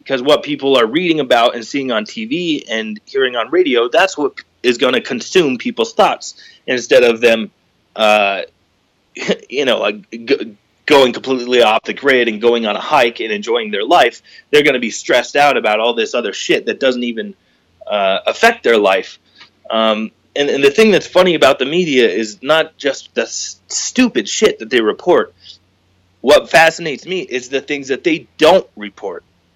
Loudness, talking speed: -14 LUFS, 185 wpm